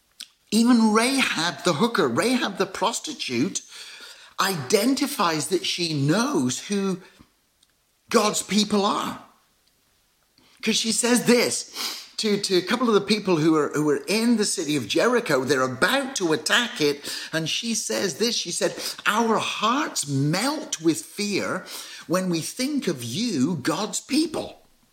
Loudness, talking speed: -23 LUFS, 140 wpm